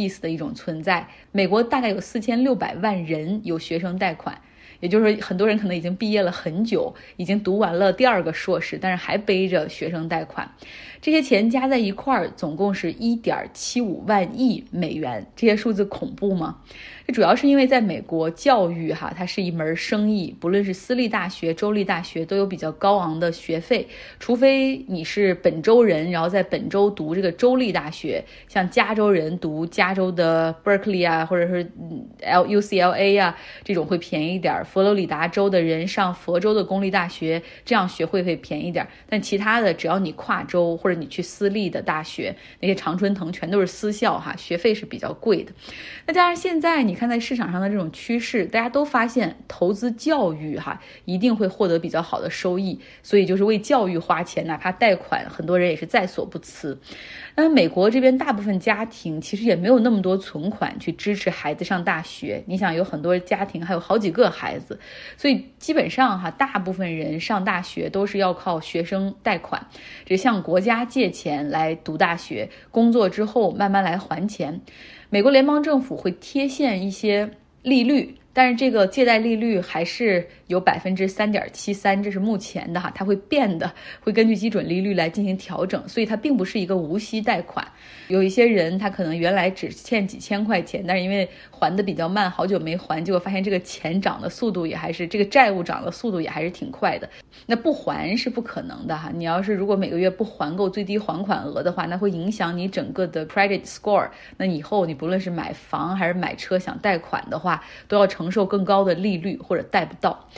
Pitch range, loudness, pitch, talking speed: 175-220 Hz, -22 LUFS, 195 Hz, 315 characters per minute